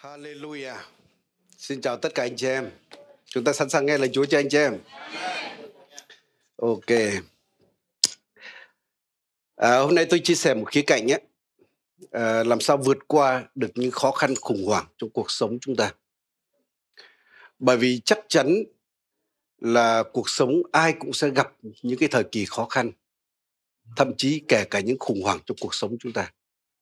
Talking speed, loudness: 170 wpm, -23 LUFS